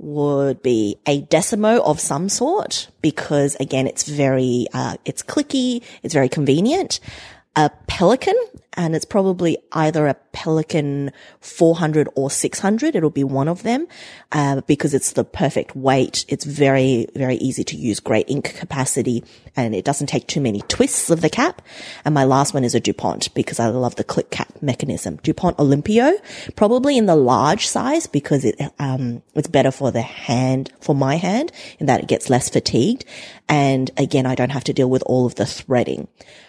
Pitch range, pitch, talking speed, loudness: 130-170 Hz, 145 Hz, 180 wpm, -19 LUFS